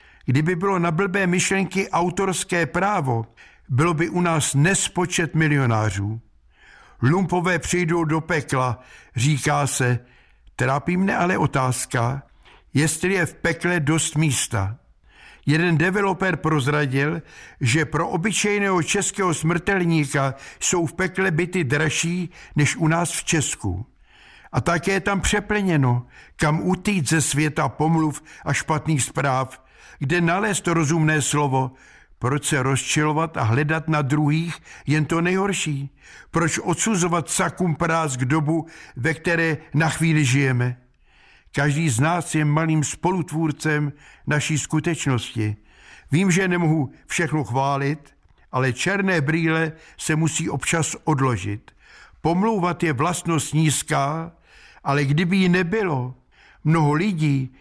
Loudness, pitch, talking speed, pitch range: -21 LUFS, 160 Hz, 120 wpm, 140-175 Hz